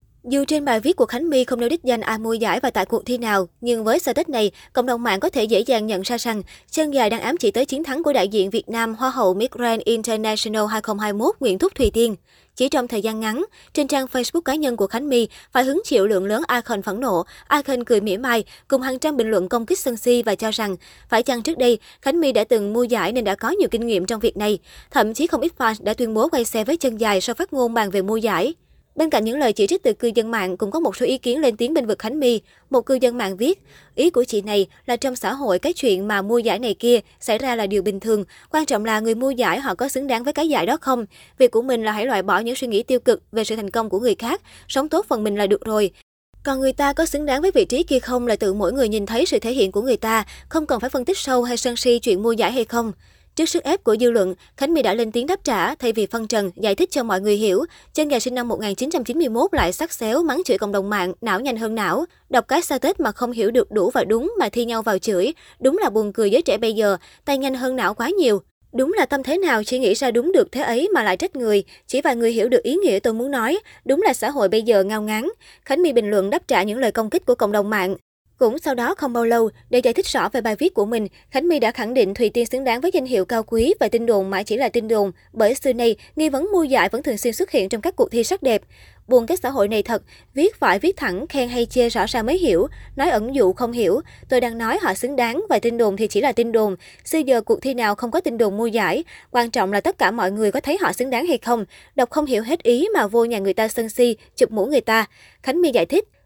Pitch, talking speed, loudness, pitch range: 240 Hz, 290 wpm, -20 LUFS, 220-280 Hz